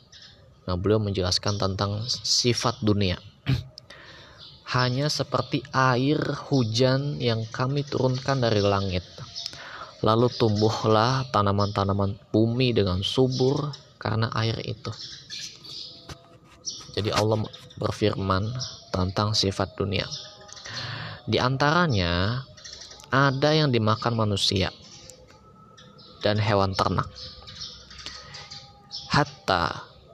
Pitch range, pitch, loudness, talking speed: 105-130 Hz, 115 Hz, -25 LUFS, 80 wpm